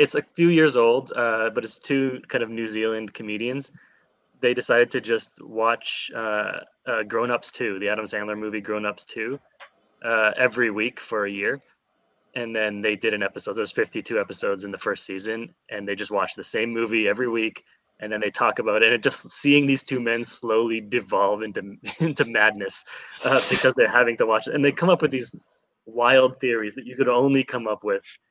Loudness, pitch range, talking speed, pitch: -23 LUFS, 110-135 Hz, 210 wpm, 115 Hz